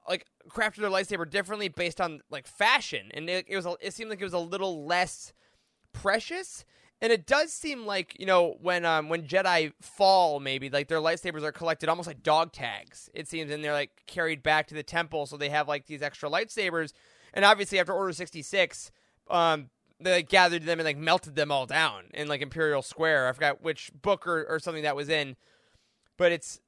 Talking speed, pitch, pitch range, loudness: 210 wpm, 170 Hz, 150-190 Hz, -28 LUFS